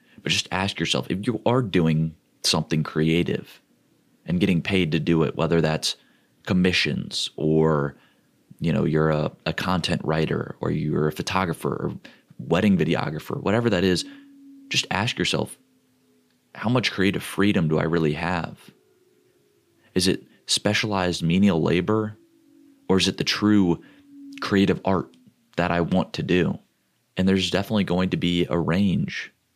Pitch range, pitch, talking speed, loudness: 80-100 Hz, 90 Hz, 145 wpm, -23 LUFS